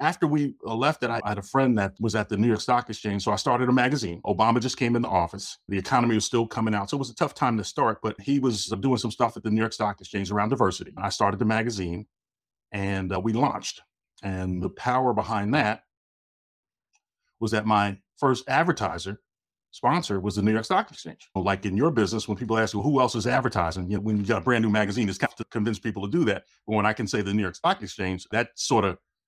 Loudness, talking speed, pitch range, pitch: -25 LUFS, 250 wpm, 100-120 Hz, 110 Hz